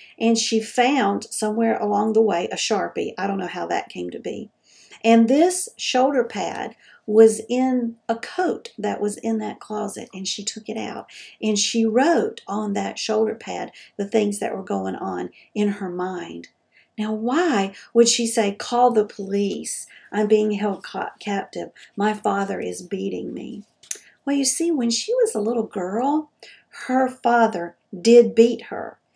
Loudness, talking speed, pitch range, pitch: -22 LUFS, 170 wpm, 205-240 Hz, 220 Hz